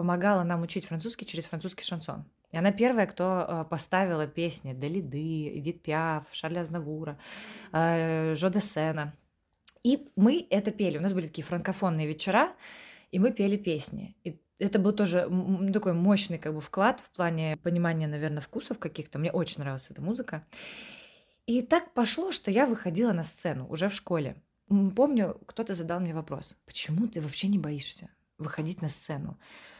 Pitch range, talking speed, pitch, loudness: 160-205 Hz, 155 wpm, 175 Hz, -30 LUFS